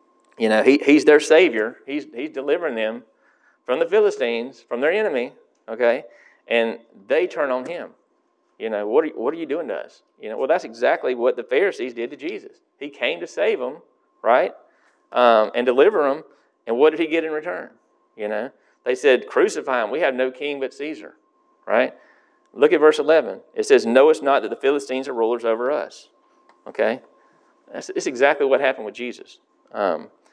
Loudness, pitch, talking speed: -20 LUFS, 285 Hz, 195 wpm